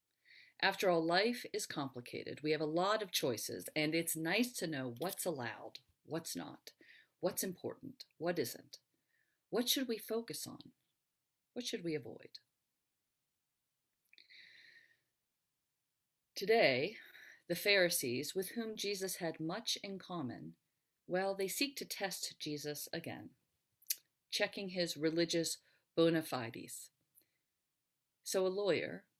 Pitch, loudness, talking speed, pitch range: 185 Hz, -38 LUFS, 120 wpm, 160-225 Hz